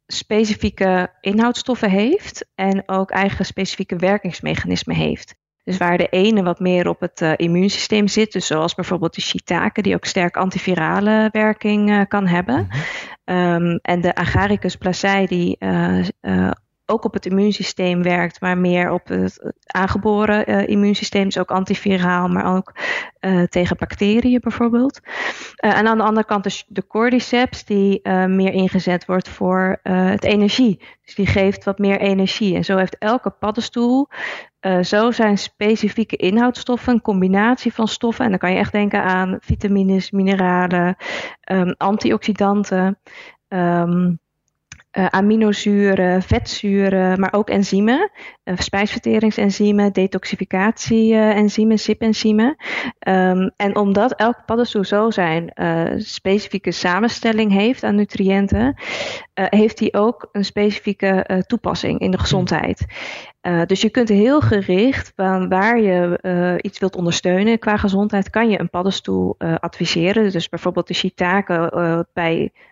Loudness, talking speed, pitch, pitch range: -18 LUFS, 140 wpm, 195 Hz, 180-215 Hz